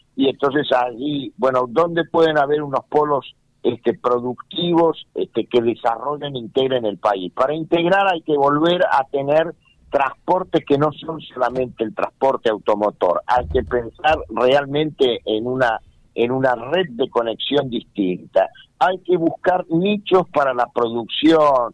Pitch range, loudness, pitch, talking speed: 125-165 Hz, -19 LUFS, 145 Hz, 145 wpm